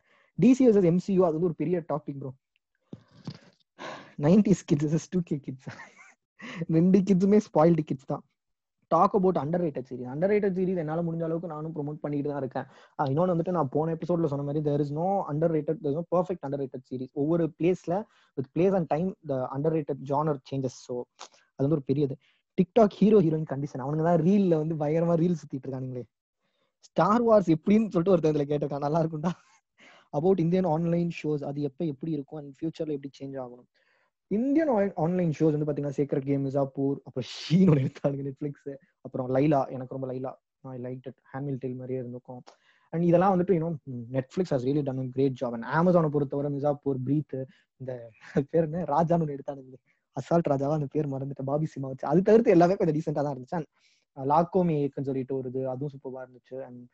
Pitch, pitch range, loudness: 150 Hz, 135-170 Hz, -27 LUFS